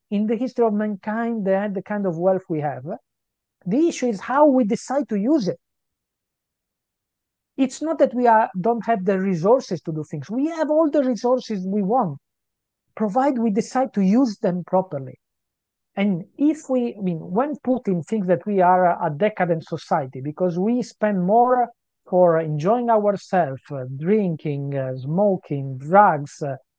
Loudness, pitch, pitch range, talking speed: -21 LUFS, 205 Hz, 170-240 Hz, 170 wpm